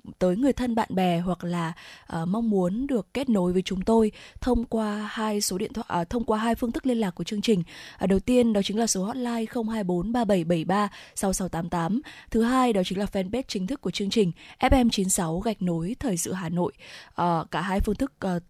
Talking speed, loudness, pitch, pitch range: 215 wpm, -26 LUFS, 205 Hz, 180-230 Hz